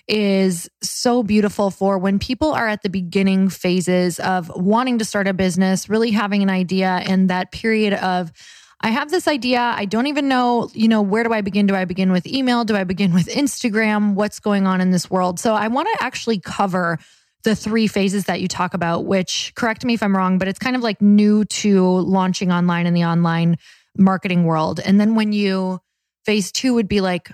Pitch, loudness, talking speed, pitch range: 195 Hz, -18 LUFS, 215 wpm, 185-220 Hz